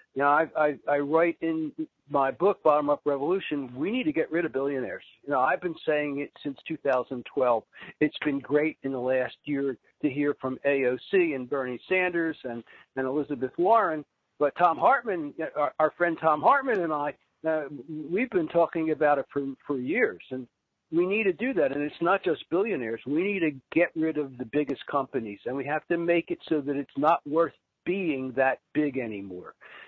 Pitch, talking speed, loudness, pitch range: 150 Hz, 200 wpm, -27 LUFS, 135-165 Hz